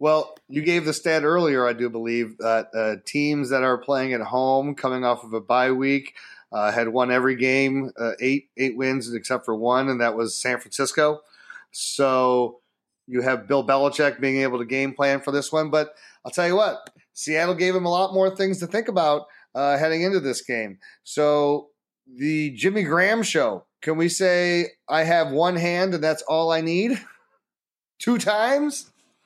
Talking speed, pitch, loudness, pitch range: 190 wpm, 140 Hz, -22 LUFS, 125-170 Hz